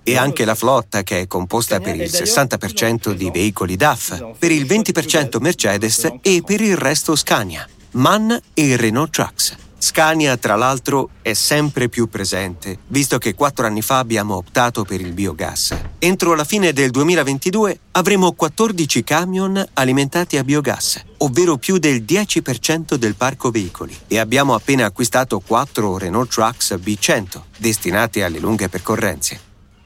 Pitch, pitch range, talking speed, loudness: 130 Hz, 105-160 Hz, 145 wpm, -17 LUFS